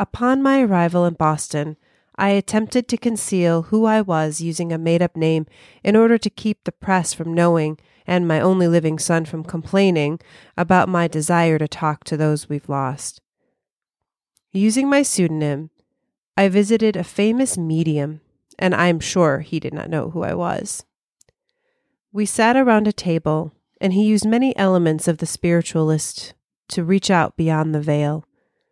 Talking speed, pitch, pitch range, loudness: 165 wpm, 170 Hz, 155-210 Hz, -19 LUFS